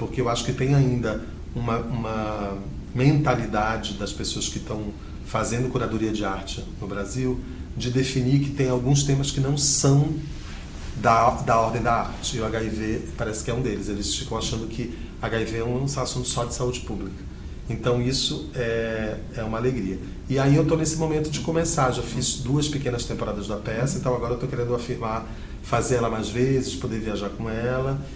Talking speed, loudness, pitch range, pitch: 190 wpm, -25 LUFS, 110-130 Hz, 120 Hz